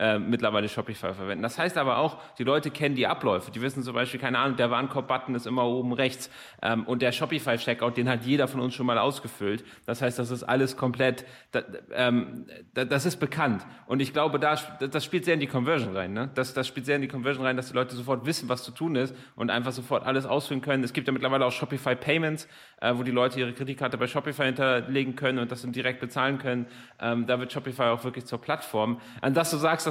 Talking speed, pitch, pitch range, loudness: 235 wpm, 130 Hz, 125-140 Hz, -28 LUFS